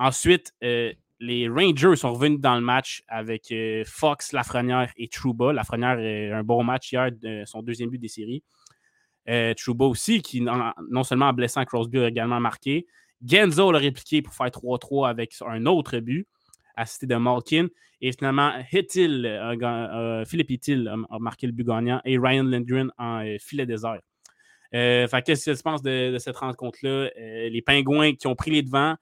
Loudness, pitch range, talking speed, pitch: -24 LUFS, 115-140 Hz, 190 wpm, 125 Hz